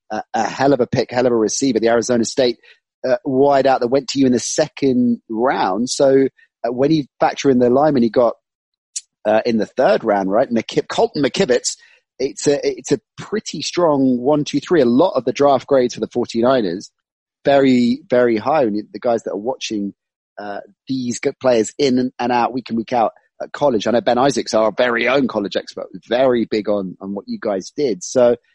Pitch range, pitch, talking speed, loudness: 115-140 Hz, 125 Hz, 220 wpm, -17 LUFS